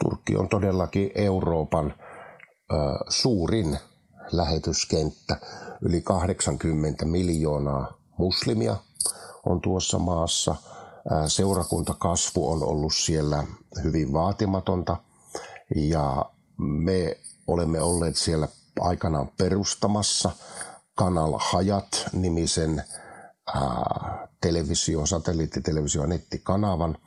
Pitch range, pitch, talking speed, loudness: 80-95 Hz, 85 Hz, 70 wpm, -26 LUFS